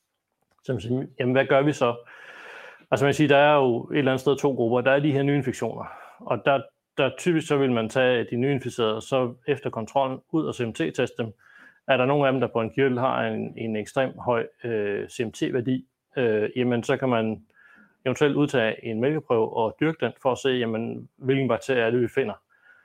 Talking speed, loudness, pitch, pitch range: 205 wpm, -24 LUFS, 130 Hz, 120-140 Hz